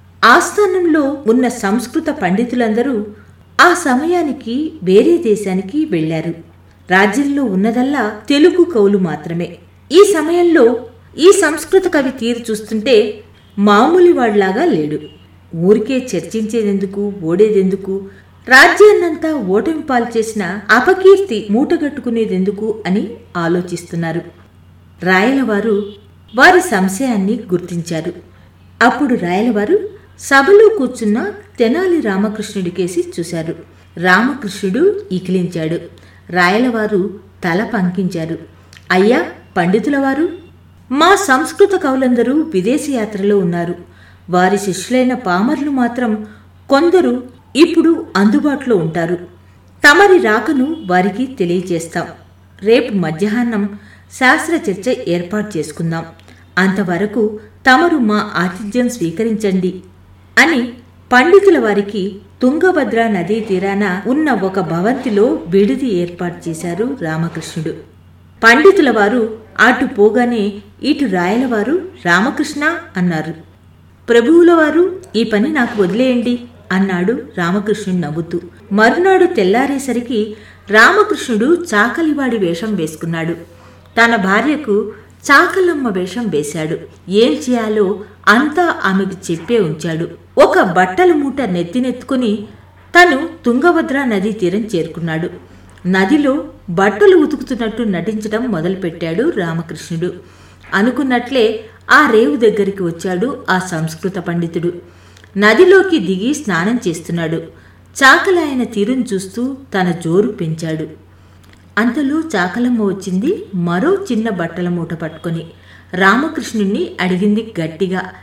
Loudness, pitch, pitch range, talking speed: -14 LUFS, 215 Hz, 180-265 Hz, 90 wpm